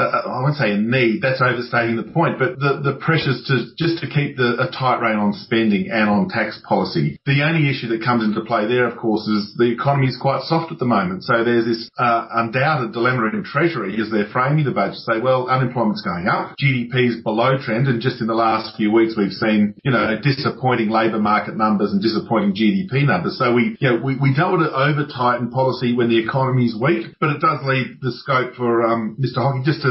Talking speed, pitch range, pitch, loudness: 235 wpm, 115-135 Hz, 125 Hz, -19 LUFS